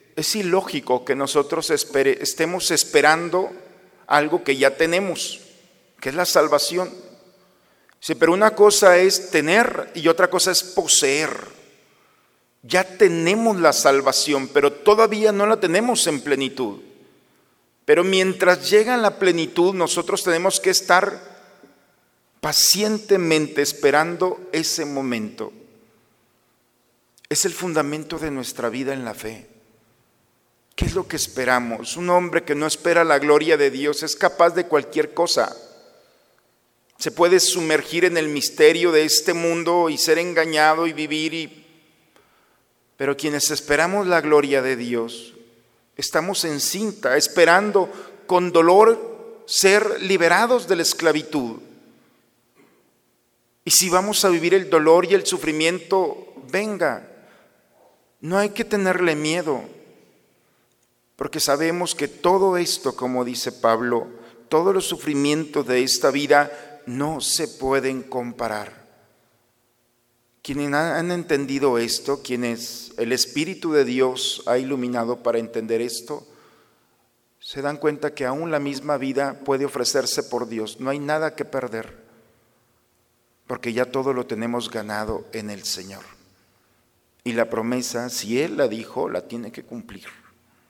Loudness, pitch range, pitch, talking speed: -20 LUFS, 125-180 Hz, 155 Hz, 130 wpm